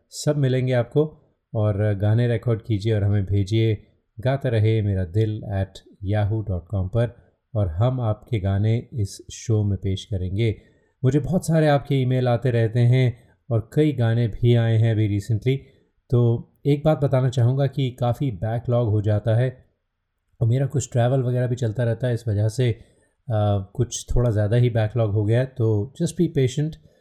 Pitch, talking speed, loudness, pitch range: 115 Hz, 175 wpm, -22 LUFS, 105-130 Hz